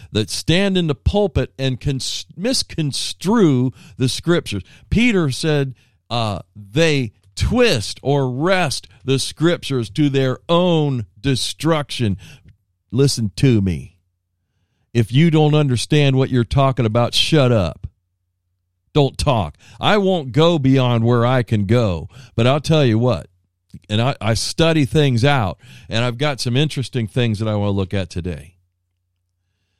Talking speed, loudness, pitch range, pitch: 140 wpm, -18 LUFS, 100-145 Hz, 120 Hz